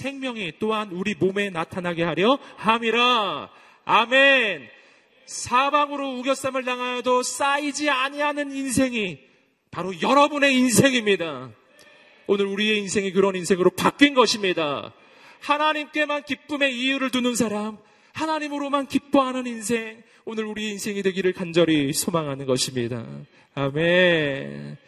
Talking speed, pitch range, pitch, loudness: 300 characters per minute, 185-270 Hz, 225 Hz, -22 LUFS